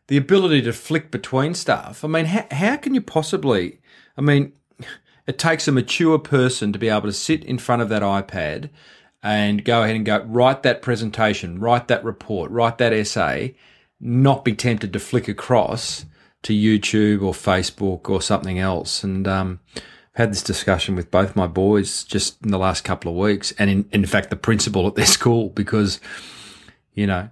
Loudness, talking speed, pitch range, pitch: -20 LUFS, 190 wpm, 100-125 Hz, 110 Hz